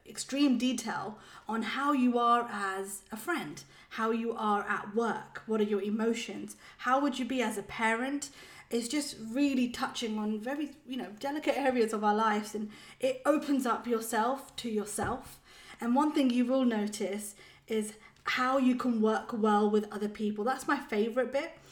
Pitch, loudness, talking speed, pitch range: 230 Hz, -31 LUFS, 175 wpm, 215-265 Hz